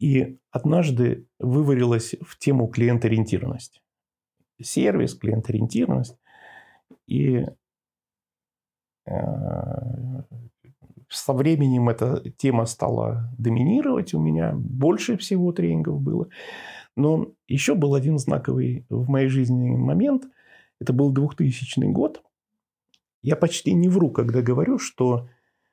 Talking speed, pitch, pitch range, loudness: 95 wpm, 130 Hz, 120-145 Hz, -23 LUFS